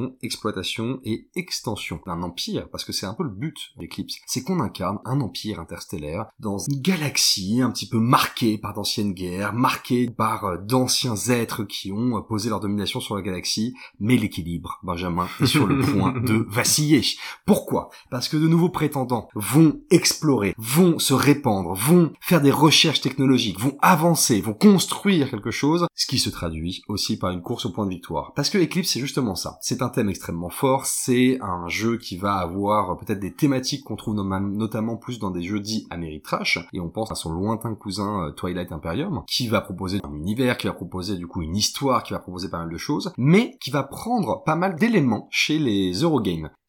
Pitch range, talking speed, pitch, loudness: 95-135 Hz, 195 wpm, 110 Hz, -22 LUFS